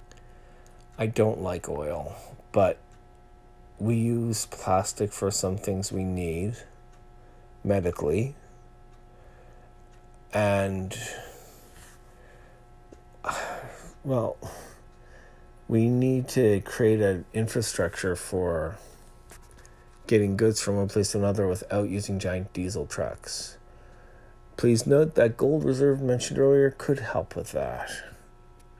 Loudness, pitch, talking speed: -27 LUFS, 95 Hz, 95 wpm